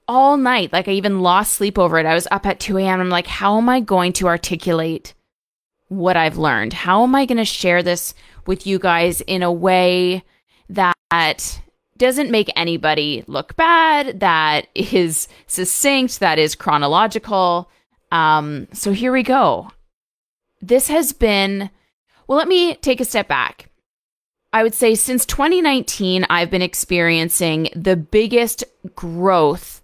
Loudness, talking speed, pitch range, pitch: -16 LUFS, 155 wpm, 175-235 Hz, 190 Hz